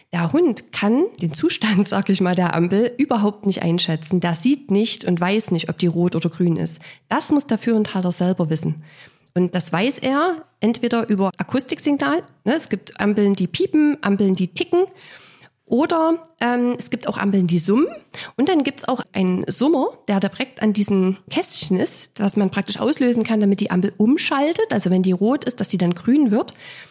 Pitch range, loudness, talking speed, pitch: 180-260 Hz, -19 LUFS, 195 wpm, 205 Hz